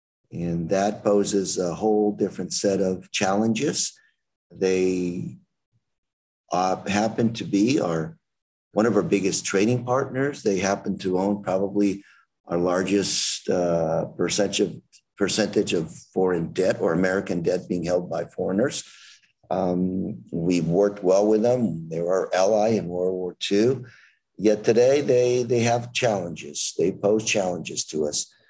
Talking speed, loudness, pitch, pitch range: 140 wpm, -23 LUFS, 95 Hz, 90-105 Hz